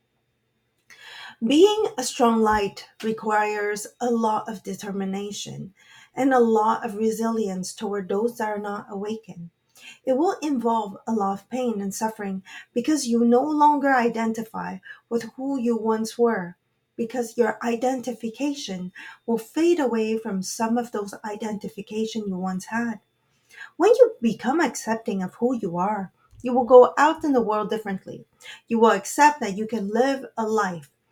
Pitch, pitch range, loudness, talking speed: 225 Hz, 205-245 Hz, -23 LUFS, 150 wpm